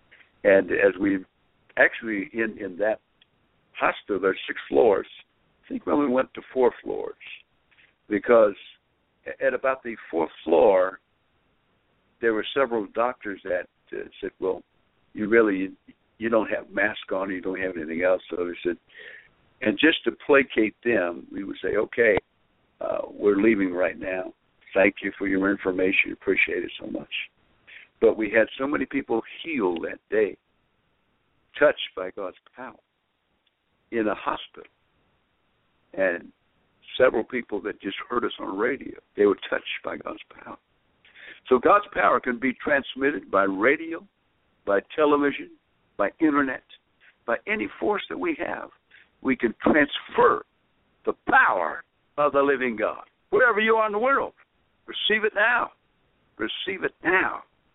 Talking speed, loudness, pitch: 150 wpm, -24 LUFS, 145 Hz